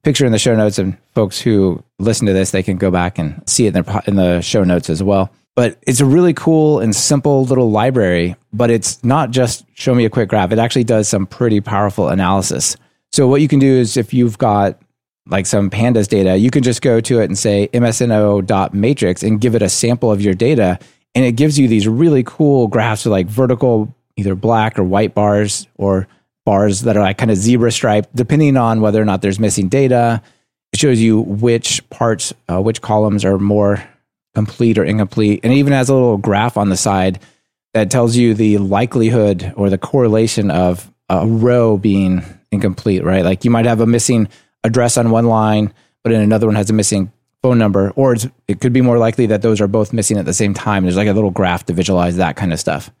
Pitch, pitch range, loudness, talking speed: 110 Hz, 100-120 Hz, -14 LUFS, 220 wpm